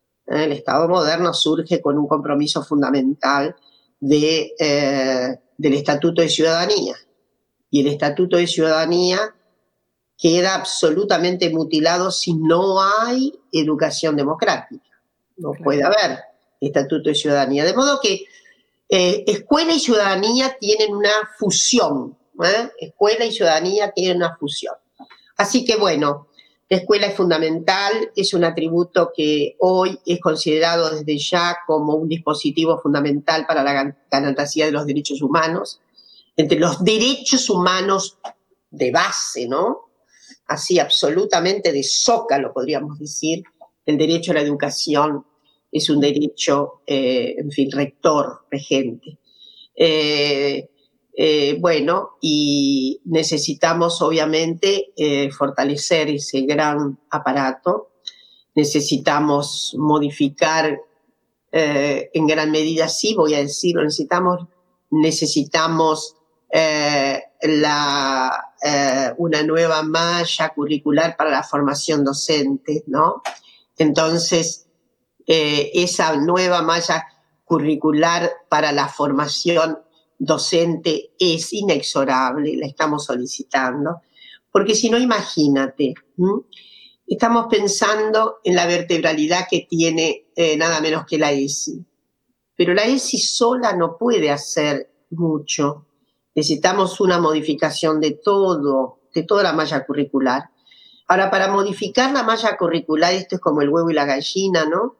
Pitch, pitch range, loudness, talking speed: 160 Hz, 145-180 Hz, -18 LUFS, 120 wpm